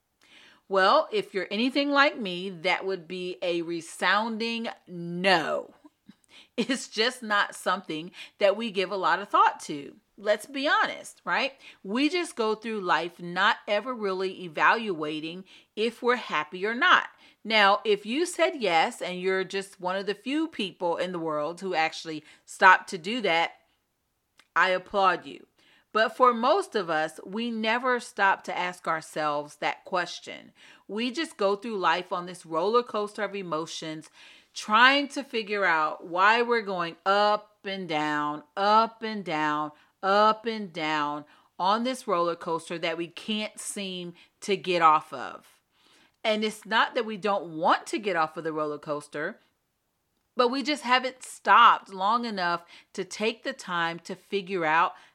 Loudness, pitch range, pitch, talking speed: -26 LUFS, 175-230 Hz, 195 Hz, 160 wpm